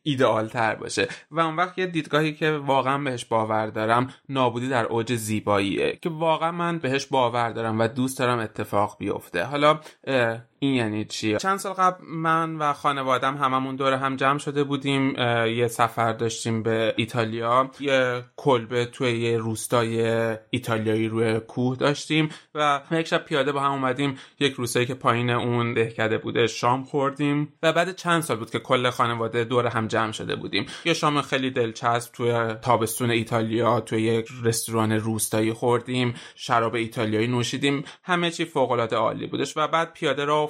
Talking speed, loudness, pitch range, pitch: 165 wpm, -24 LUFS, 115-145 Hz, 125 Hz